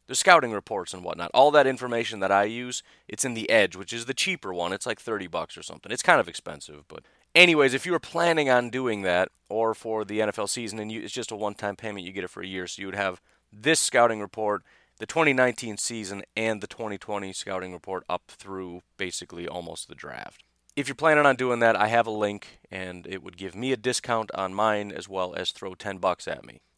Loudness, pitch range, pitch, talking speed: -25 LUFS, 95-125 Hz, 105 Hz, 235 wpm